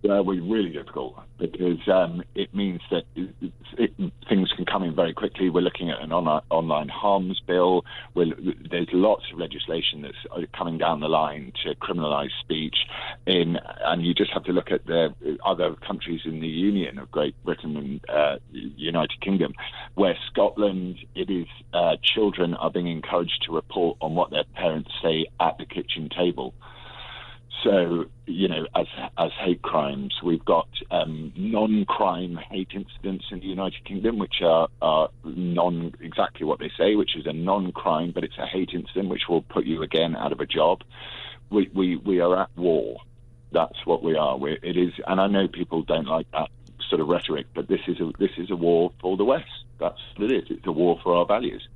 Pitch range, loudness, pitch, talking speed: 85-100 Hz, -25 LUFS, 90 Hz, 190 wpm